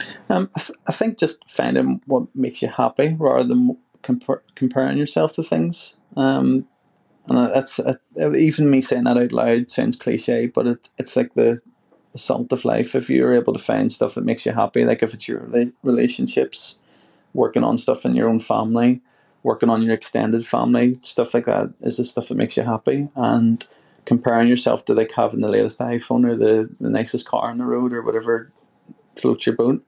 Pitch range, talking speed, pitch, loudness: 115-135 Hz, 195 wpm, 120 Hz, -20 LUFS